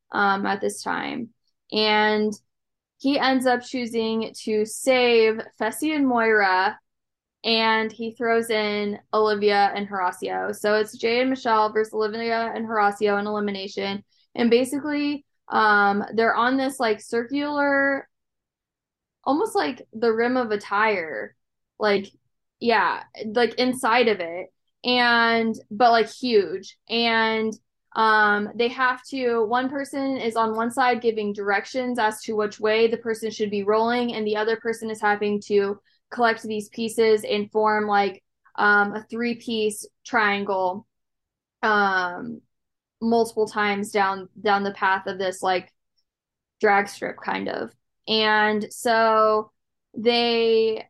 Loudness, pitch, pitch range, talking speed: -22 LUFS, 220 Hz, 210-235 Hz, 135 wpm